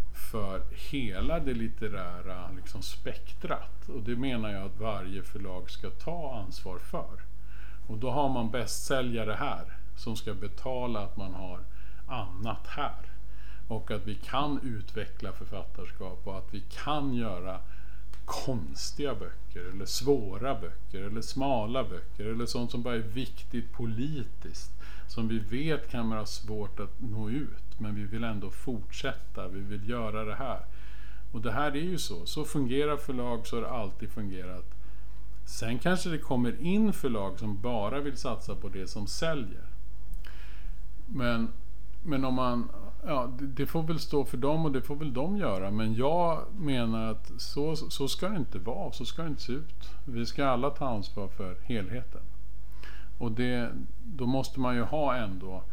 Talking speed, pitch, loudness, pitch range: 165 wpm, 115 Hz, -34 LUFS, 95-135 Hz